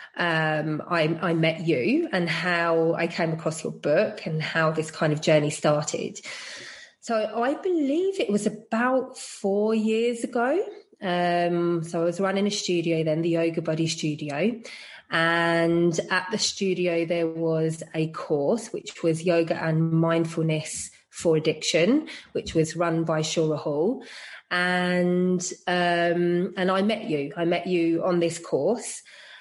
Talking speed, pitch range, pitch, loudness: 150 wpm, 160-195 Hz, 170 Hz, -25 LUFS